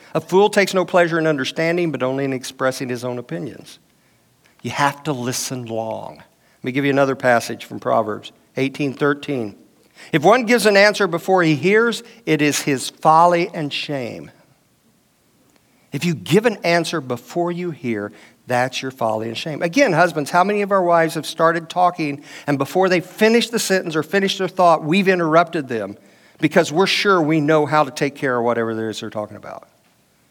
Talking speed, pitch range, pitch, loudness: 185 wpm, 130-180 Hz, 155 Hz, -18 LUFS